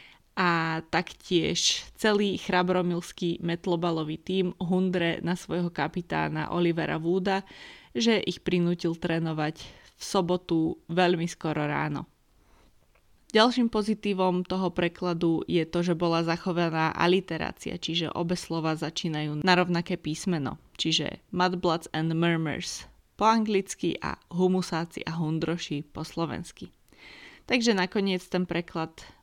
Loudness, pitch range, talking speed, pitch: -28 LUFS, 165-185 Hz, 110 wpm, 175 Hz